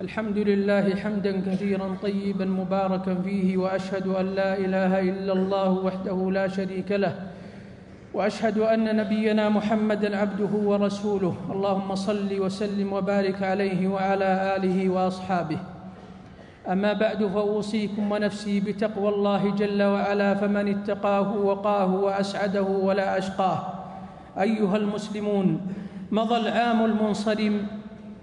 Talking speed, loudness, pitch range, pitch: 105 wpm, -25 LUFS, 190-210 Hz, 200 Hz